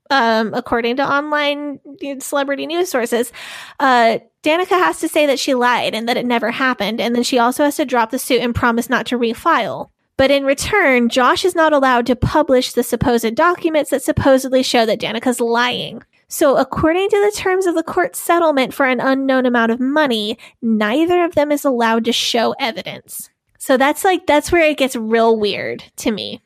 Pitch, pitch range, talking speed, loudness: 265 Hz, 240-300 Hz, 195 wpm, -16 LUFS